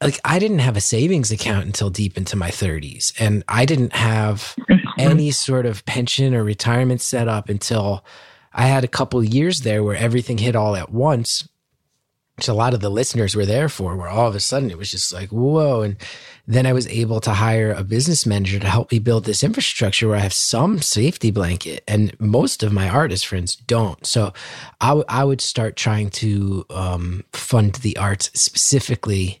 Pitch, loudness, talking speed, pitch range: 115 Hz, -19 LUFS, 200 wpm, 100-130 Hz